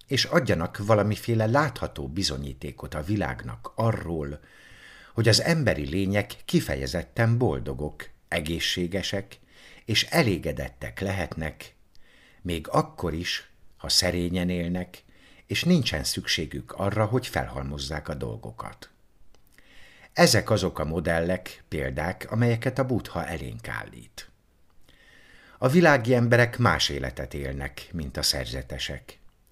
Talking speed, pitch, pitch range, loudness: 105 wpm, 90 Hz, 75-110 Hz, -26 LUFS